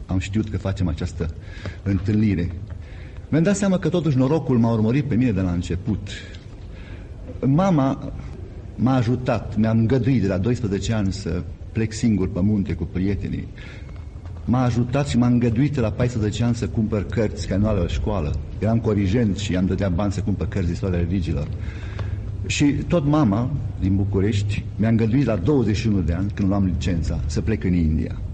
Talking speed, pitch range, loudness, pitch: 170 wpm, 90-115 Hz, -22 LUFS, 100 Hz